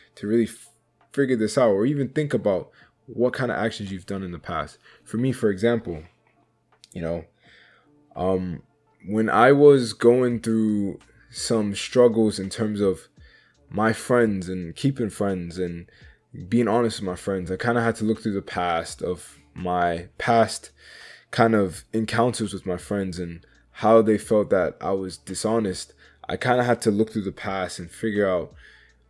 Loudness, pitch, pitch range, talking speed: -23 LUFS, 110 Hz, 95-115 Hz, 175 wpm